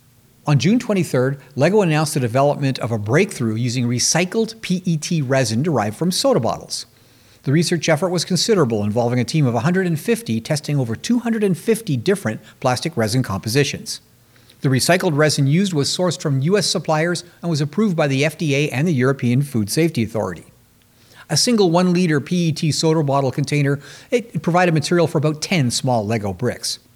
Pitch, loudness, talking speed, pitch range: 150 Hz, -19 LUFS, 165 wpm, 125-175 Hz